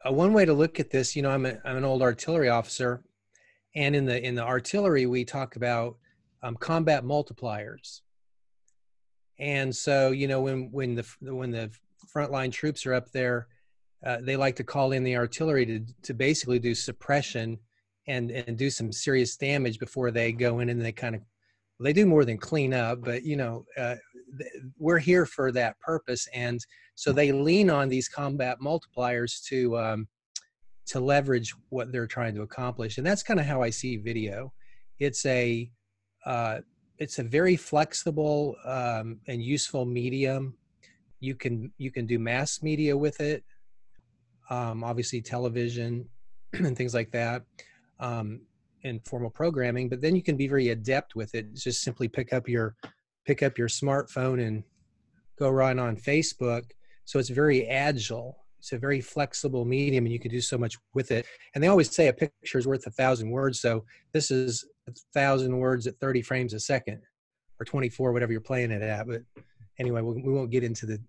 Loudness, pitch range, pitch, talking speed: -28 LUFS, 120-140 Hz, 125 Hz, 185 wpm